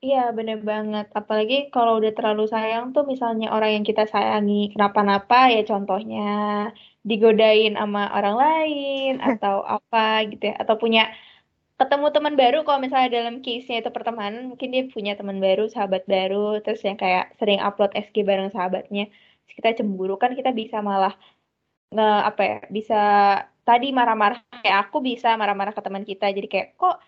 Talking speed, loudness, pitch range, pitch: 165 wpm, -21 LUFS, 205-240 Hz, 215 Hz